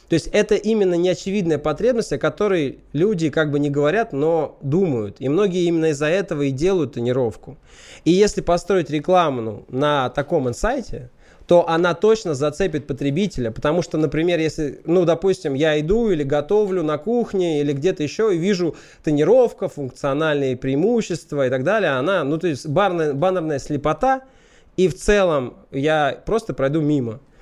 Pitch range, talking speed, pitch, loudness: 145-185 Hz, 160 wpm, 160 Hz, -20 LUFS